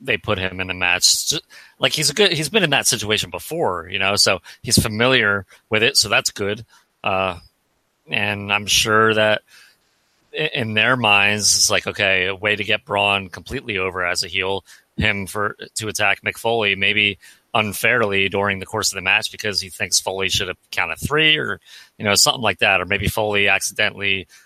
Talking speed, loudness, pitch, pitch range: 190 wpm, -18 LUFS, 105 Hz, 95-110 Hz